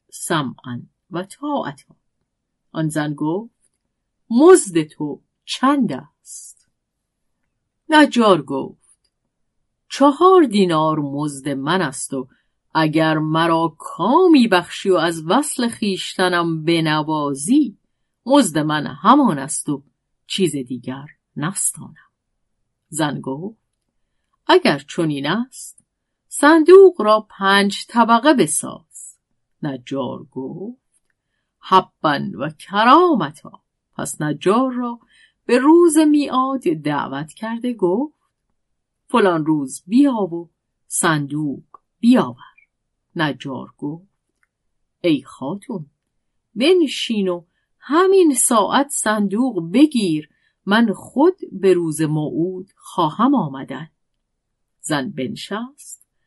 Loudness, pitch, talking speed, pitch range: -17 LUFS, 185 Hz, 90 wpm, 155-255 Hz